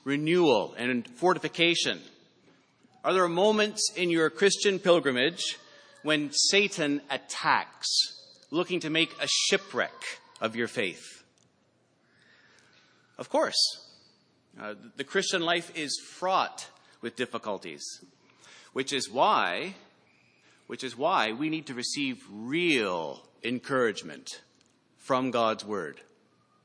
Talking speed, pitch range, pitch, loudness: 105 wpm, 130-190 Hz, 160 Hz, -27 LUFS